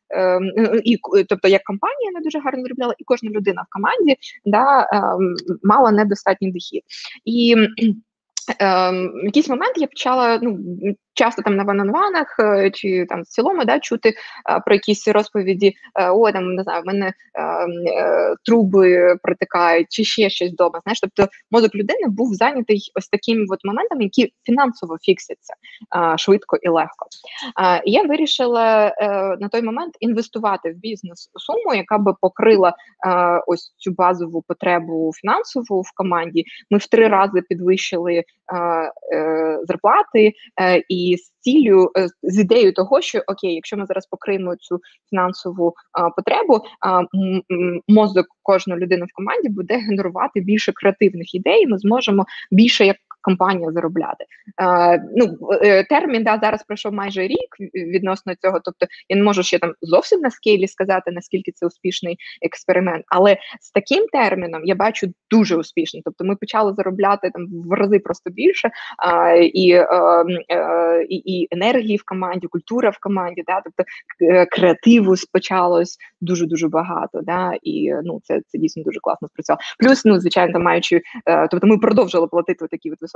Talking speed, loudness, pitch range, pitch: 155 wpm, -17 LUFS, 180-220 Hz, 195 Hz